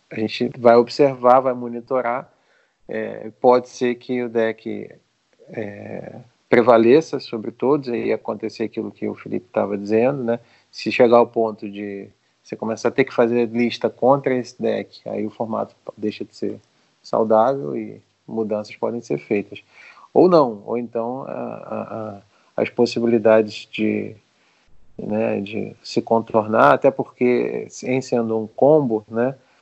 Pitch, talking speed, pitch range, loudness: 115 Hz, 150 wpm, 110-120 Hz, -20 LUFS